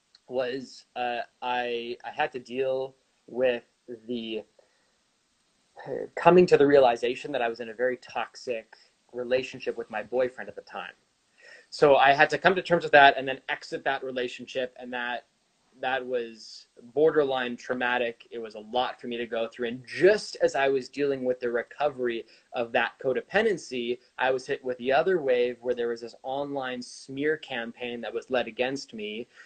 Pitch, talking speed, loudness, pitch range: 125 Hz, 180 wpm, -27 LUFS, 120-135 Hz